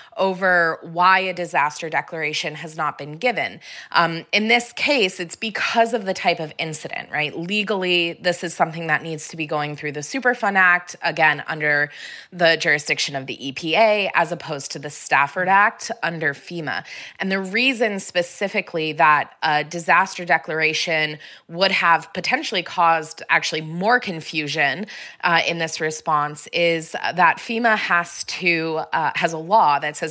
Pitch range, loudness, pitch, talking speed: 155-190 Hz, -20 LUFS, 170 Hz, 155 wpm